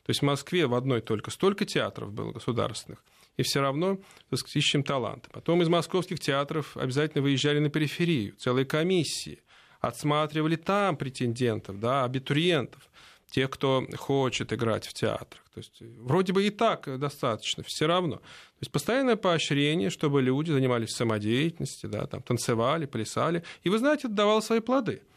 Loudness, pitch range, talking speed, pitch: -28 LUFS, 130-175 Hz, 155 wpm, 145 Hz